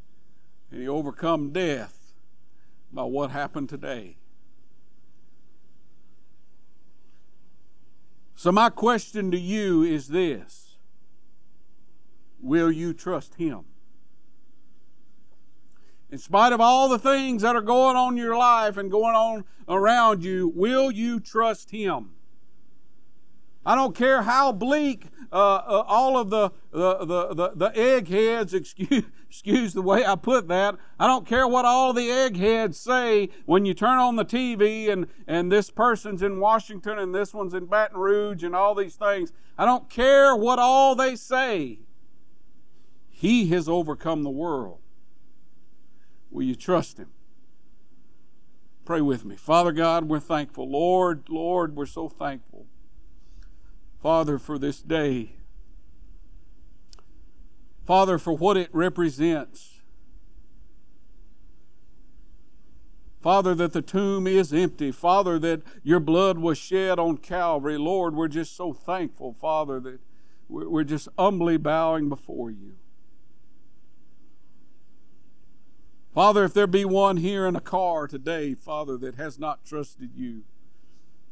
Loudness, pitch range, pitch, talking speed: -23 LUFS, 155-220 Hz, 180 Hz, 130 wpm